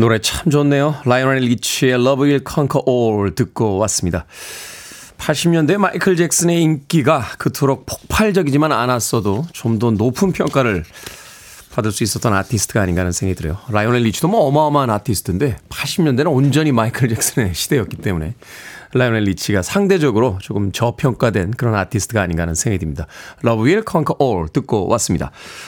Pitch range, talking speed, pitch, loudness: 105-145 Hz, 440 characters per minute, 125 Hz, -17 LUFS